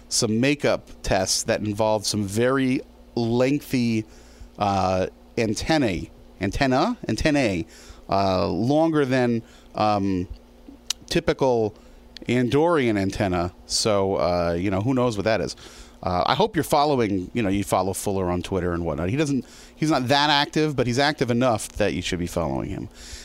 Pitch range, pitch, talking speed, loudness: 90-130 Hz, 105 Hz, 150 wpm, -23 LUFS